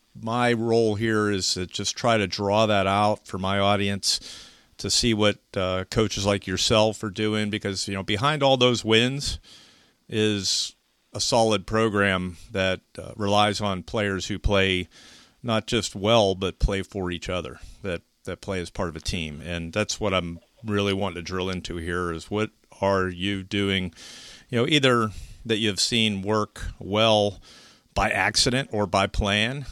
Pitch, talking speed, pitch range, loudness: 100 Hz, 170 wpm, 95-110 Hz, -24 LUFS